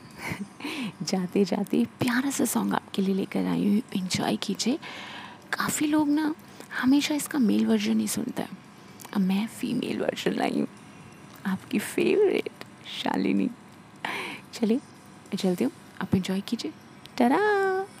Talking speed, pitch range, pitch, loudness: 125 wpm, 200-295 Hz, 225 Hz, -27 LUFS